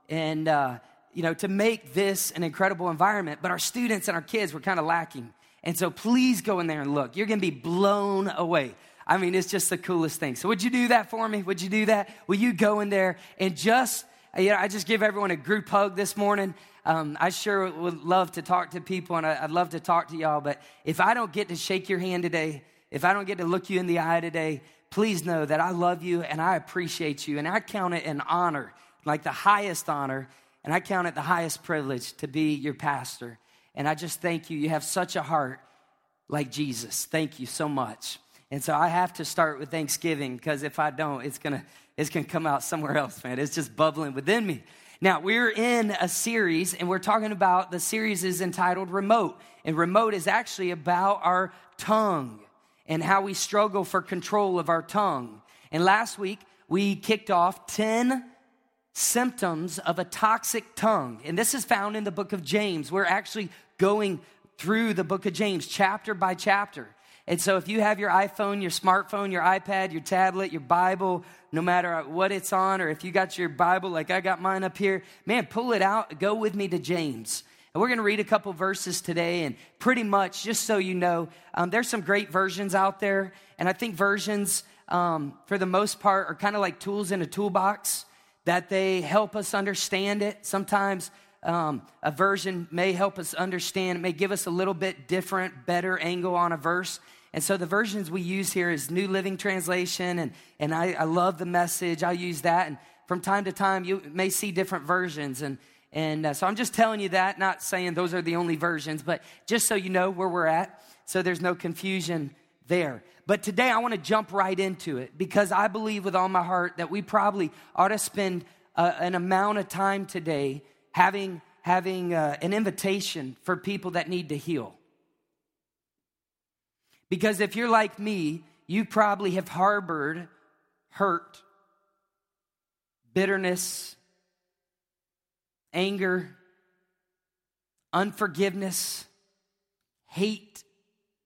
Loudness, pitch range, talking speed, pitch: -27 LUFS, 170-200 Hz, 195 wpm, 185 Hz